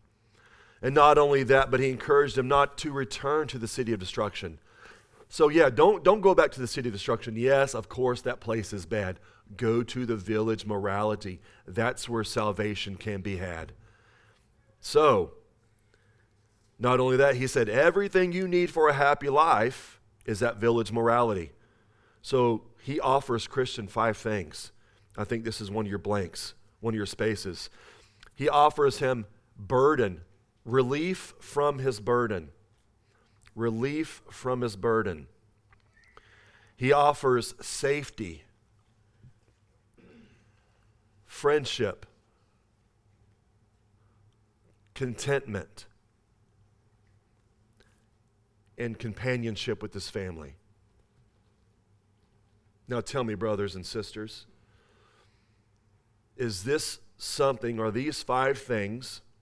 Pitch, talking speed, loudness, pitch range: 110 Hz, 115 wpm, -27 LUFS, 105-125 Hz